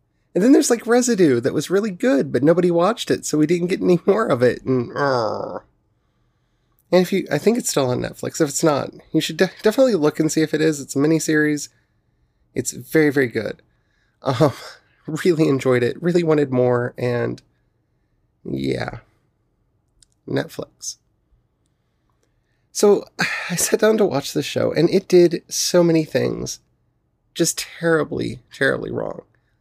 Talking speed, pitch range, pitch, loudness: 160 wpm, 135-180 Hz, 160 Hz, -19 LUFS